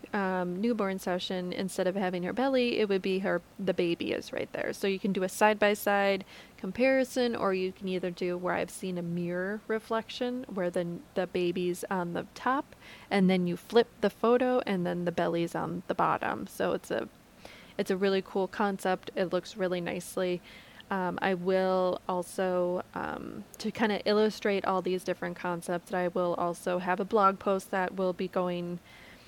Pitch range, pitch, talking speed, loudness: 180-205 Hz, 190 Hz, 190 wpm, -30 LUFS